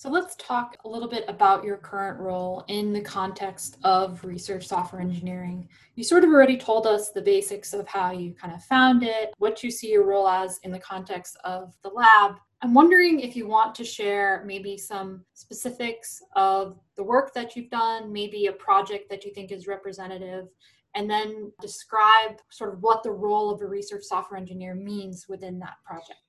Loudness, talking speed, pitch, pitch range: -23 LUFS, 195 wpm, 205 Hz, 190-225 Hz